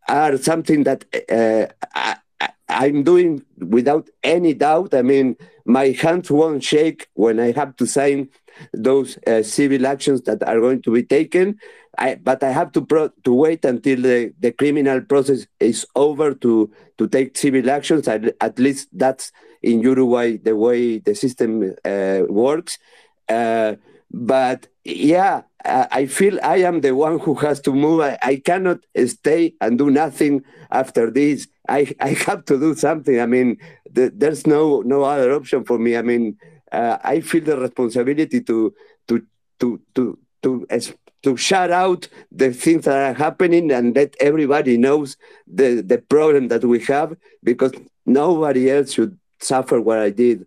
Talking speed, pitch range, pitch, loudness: 165 wpm, 120-155 Hz, 135 Hz, -18 LUFS